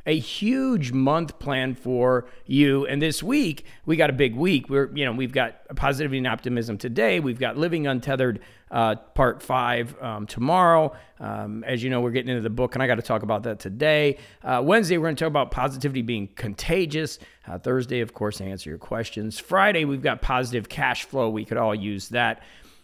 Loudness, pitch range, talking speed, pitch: -24 LUFS, 115-150 Hz, 200 wpm, 130 Hz